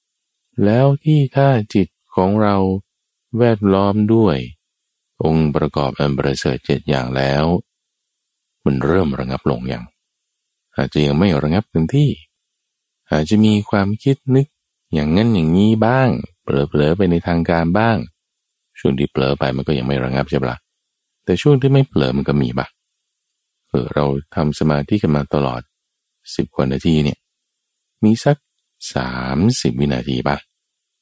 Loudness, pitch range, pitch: -17 LUFS, 70-105 Hz, 80 Hz